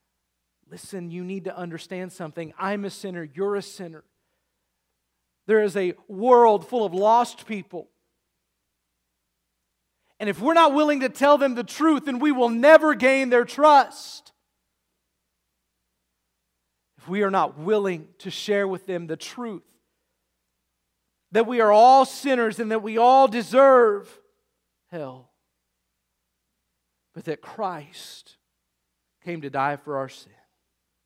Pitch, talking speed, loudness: 180 Hz, 130 wpm, -20 LUFS